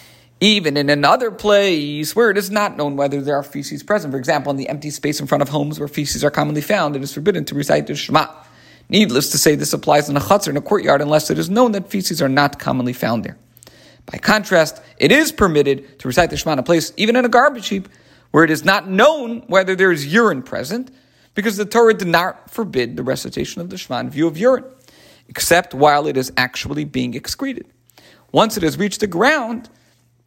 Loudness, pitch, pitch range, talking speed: -17 LUFS, 165 Hz, 145-210 Hz, 225 wpm